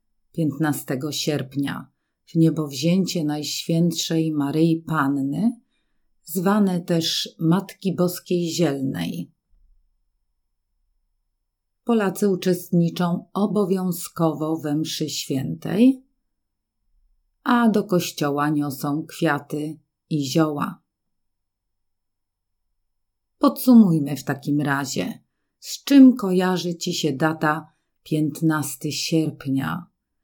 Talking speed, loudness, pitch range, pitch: 75 wpm, -22 LUFS, 135-175 Hz, 155 Hz